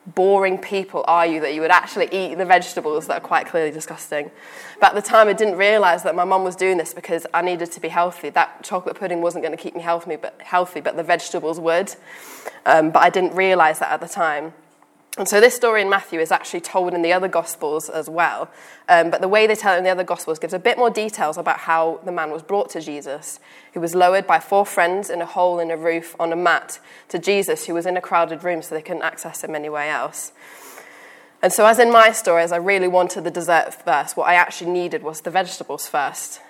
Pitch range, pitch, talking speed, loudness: 165-190 Hz, 175 Hz, 245 wpm, -19 LUFS